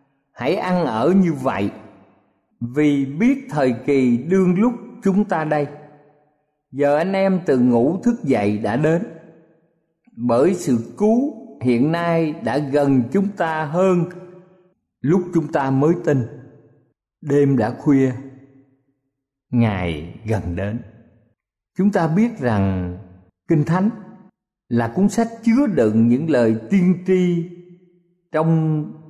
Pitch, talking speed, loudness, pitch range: 150 Hz, 125 wpm, -19 LUFS, 120-180 Hz